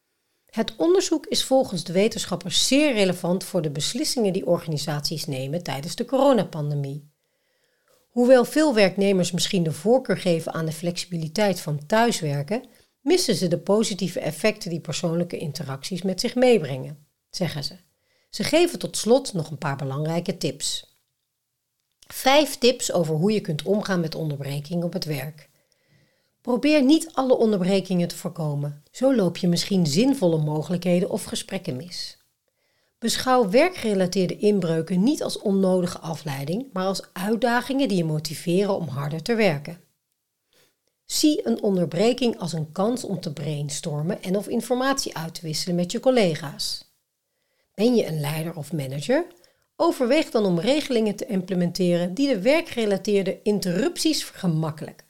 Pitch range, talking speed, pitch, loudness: 160-235 Hz, 140 wpm, 185 Hz, -23 LUFS